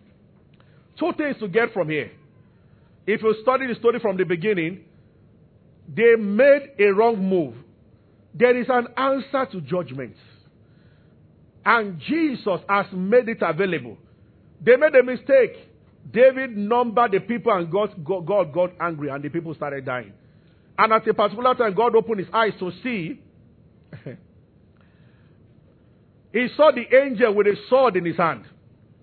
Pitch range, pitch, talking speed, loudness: 165-245 Hz, 205 Hz, 145 wpm, -21 LUFS